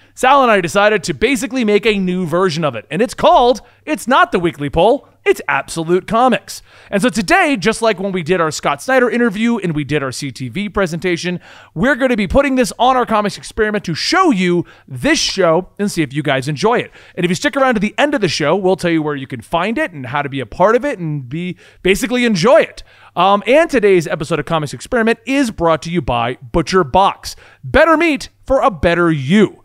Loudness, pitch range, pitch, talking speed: -15 LUFS, 165-245 Hz, 195 Hz, 235 wpm